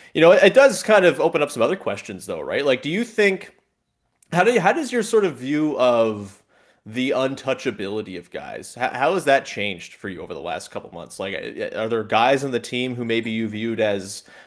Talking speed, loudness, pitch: 230 wpm, -20 LUFS, 125 Hz